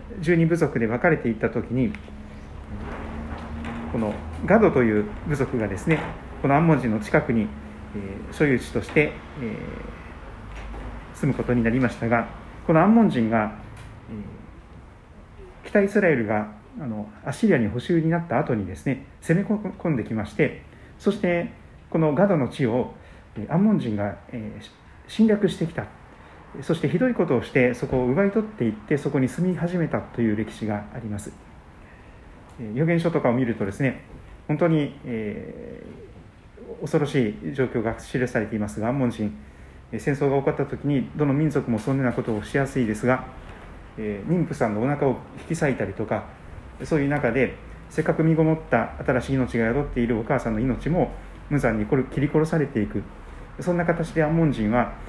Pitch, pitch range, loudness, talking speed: 120 Hz, 105-150 Hz, -24 LUFS, 330 characters per minute